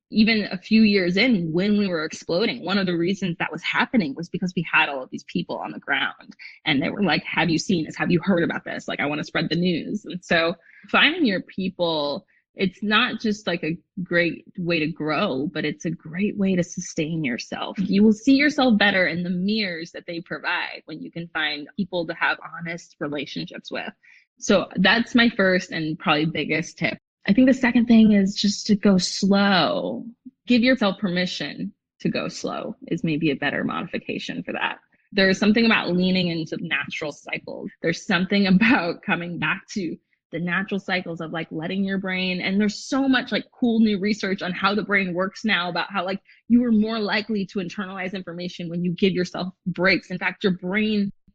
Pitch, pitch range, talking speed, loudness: 190 Hz, 170-210 Hz, 205 wpm, -22 LUFS